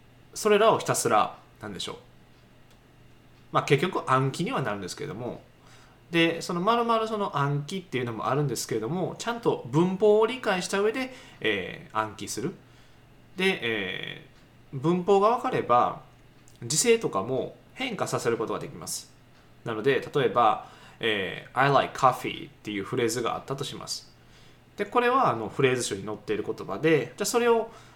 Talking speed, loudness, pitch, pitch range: 350 characters per minute, -26 LUFS, 165 Hz, 130-215 Hz